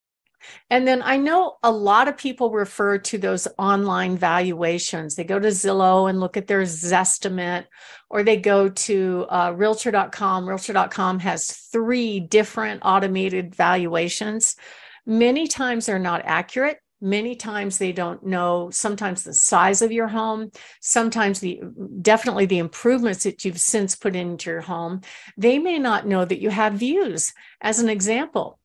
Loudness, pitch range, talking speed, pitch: -21 LUFS, 185-225 Hz, 155 wpm, 200 Hz